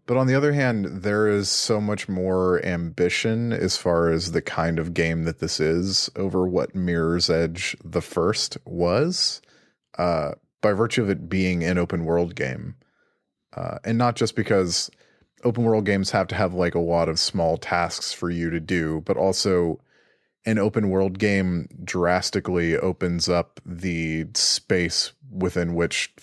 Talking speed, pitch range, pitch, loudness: 165 wpm, 85-105 Hz, 90 Hz, -23 LUFS